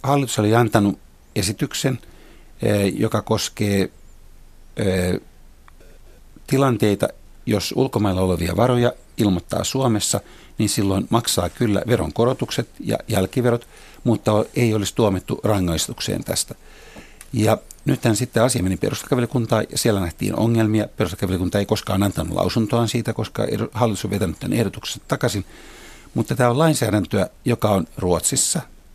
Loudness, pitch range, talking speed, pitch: -21 LUFS, 95-120 Hz, 115 wpm, 105 Hz